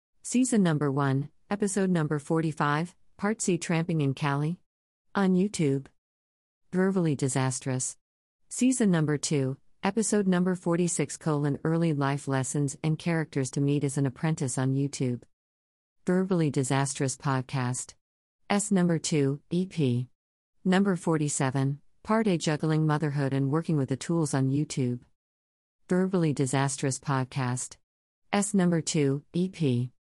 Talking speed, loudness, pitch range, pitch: 120 wpm, -28 LUFS, 135-170 Hz, 145 Hz